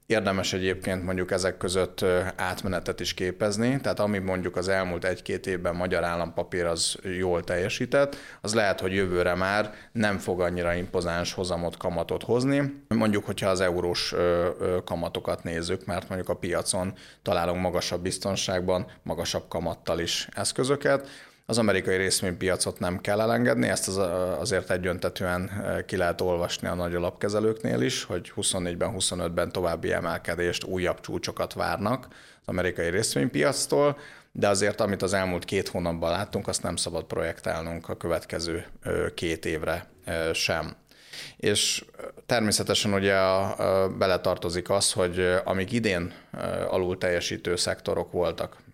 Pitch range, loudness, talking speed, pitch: 90-100 Hz, -27 LUFS, 135 wpm, 95 Hz